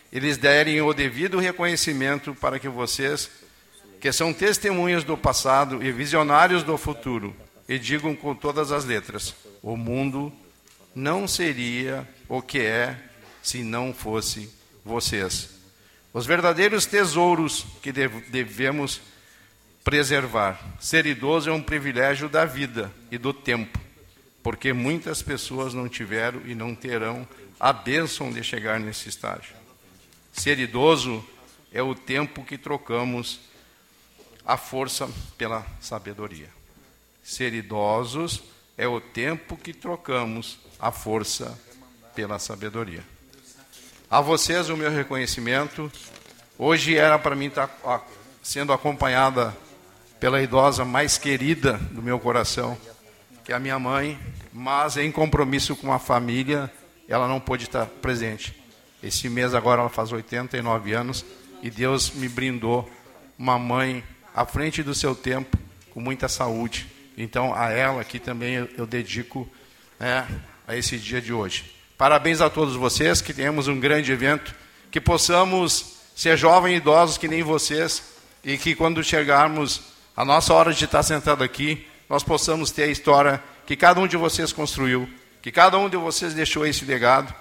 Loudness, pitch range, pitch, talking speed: -23 LUFS, 115-150 Hz, 130 Hz, 140 wpm